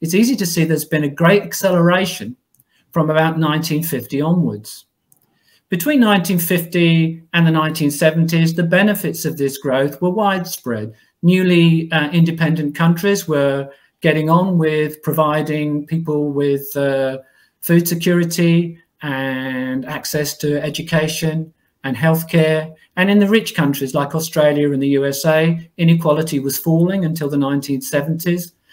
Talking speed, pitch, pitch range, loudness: 125 wpm, 160 Hz, 145-170 Hz, -17 LUFS